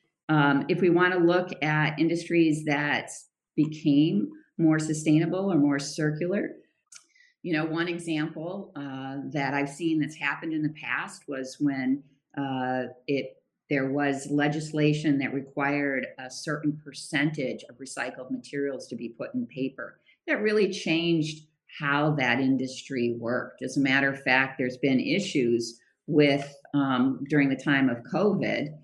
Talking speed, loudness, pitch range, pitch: 145 wpm, -27 LUFS, 135-155 Hz, 145 Hz